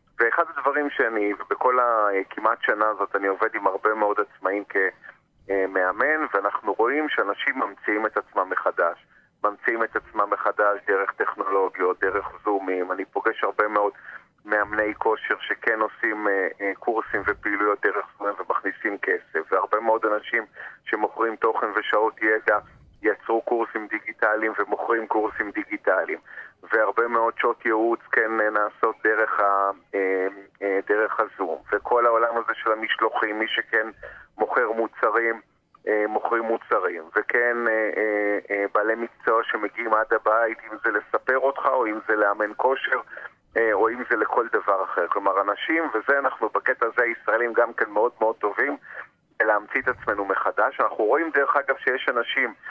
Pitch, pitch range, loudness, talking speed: 110 Hz, 100-115 Hz, -23 LUFS, 145 wpm